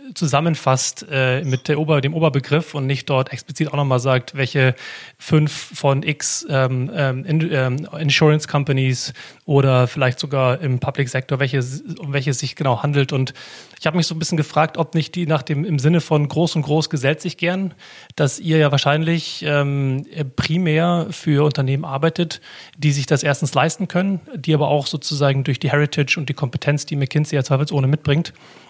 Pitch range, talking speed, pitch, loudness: 140-155 Hz, 180 wpm, 145 Hz, -19 LUFS